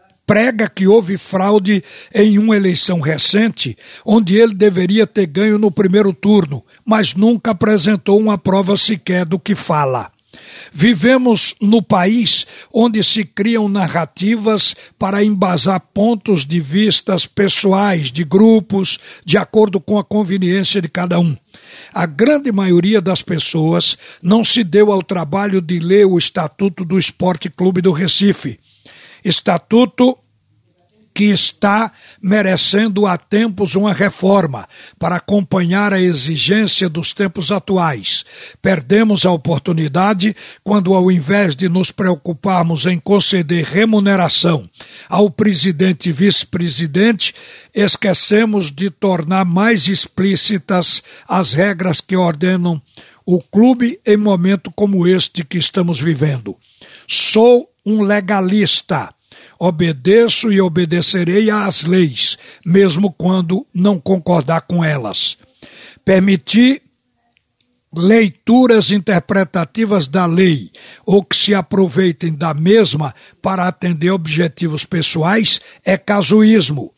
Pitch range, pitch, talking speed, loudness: 175-210 Hz, 190 Hz, 115 wpm, -13 LUFS